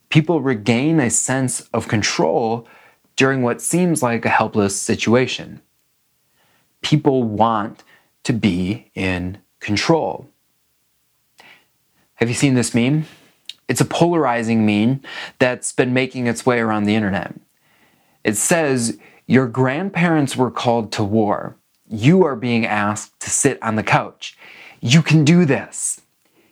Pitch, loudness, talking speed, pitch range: 120 Hz, -18 LUFS, 130 wpm, 110-135 Hz